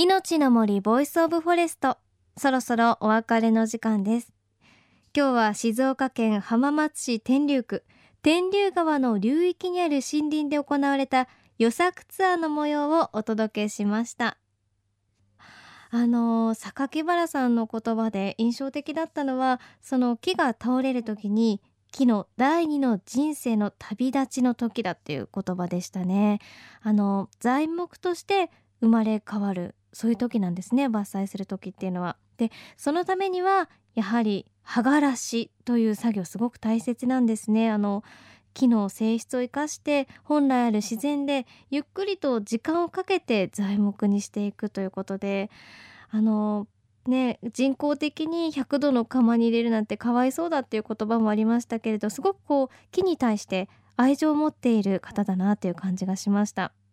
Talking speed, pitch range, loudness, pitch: 315 characters per minute, 210-285 Hz, -25 LUFS, 235 Hz